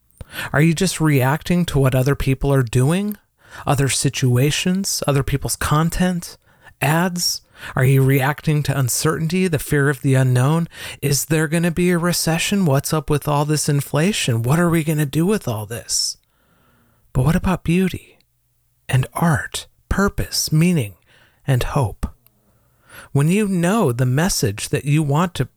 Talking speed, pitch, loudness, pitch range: 155 wpm, 145 Hz, -19 LUFS, 130-170 Hz